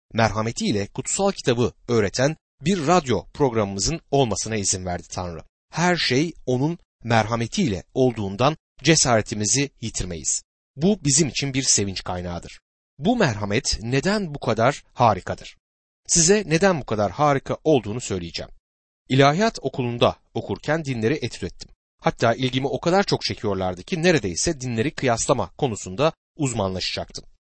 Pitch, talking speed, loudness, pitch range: 125 Hz, 120 wpm, -22 LUFS, 100-150 Hz